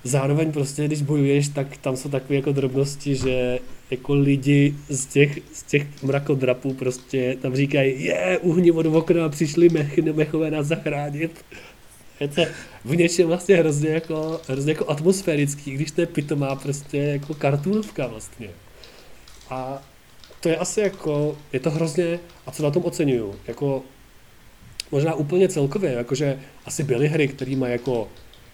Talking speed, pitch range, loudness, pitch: 150 wpm, 135-160 Hz, -22 LUFS, 145 Hz